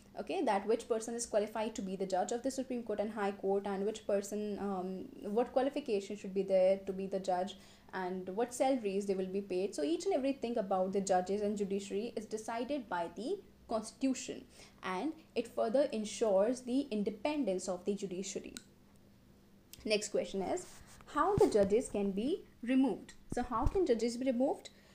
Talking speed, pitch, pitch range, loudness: 180 wpm, 215 Hz, 195-250 Hz, -36 LUFS